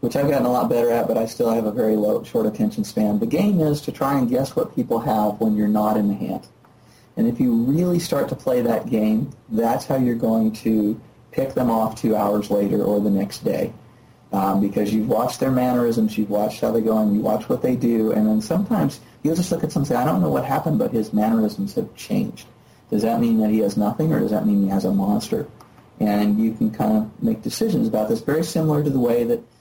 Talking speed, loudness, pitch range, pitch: 250 wpm, -21 LUFS, 105-155 Hz, 115 Hz